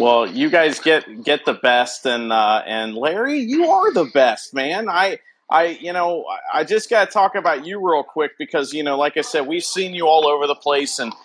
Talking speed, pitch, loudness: 225 wpm, 155 Hz, -18 LUFS